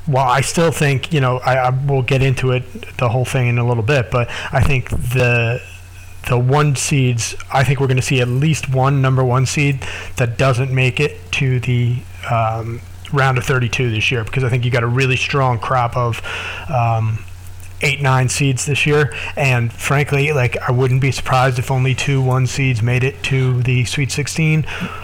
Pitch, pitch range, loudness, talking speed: 130 Hz, 120-135 Hz, -16 LUFS, 200 wpm